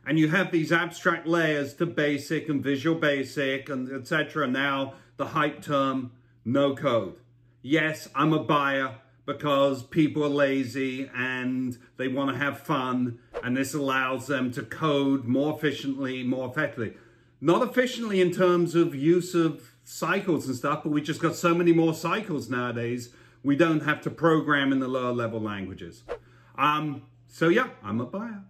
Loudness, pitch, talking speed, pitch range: -26 LUFS, 140 Hz, 165 wpm, 130-160 Hz